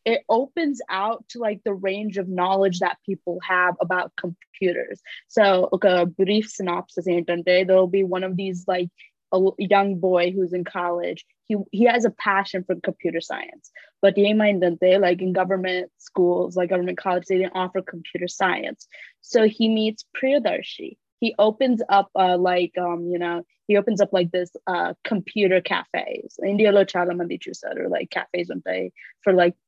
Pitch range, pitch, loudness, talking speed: 180-205 Hz, 190 Hz, -22 LUFS, 170 wpm